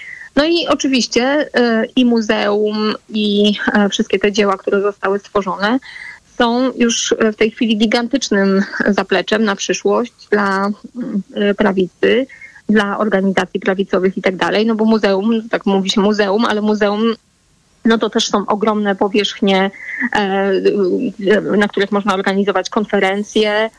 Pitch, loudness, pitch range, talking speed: 210 Hz, -15 LUFS, 200-230 Hz, 140 wpm